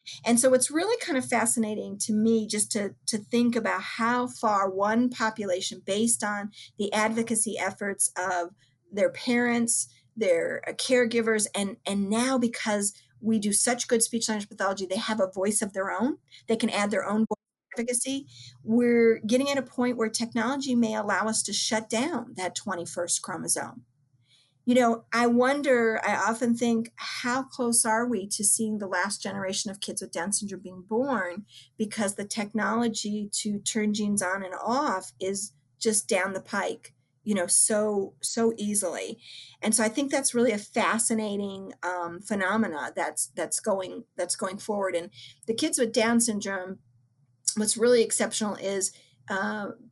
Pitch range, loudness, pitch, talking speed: 195-235 Hz, -27 LUFS, 215 Hz, 170 wpm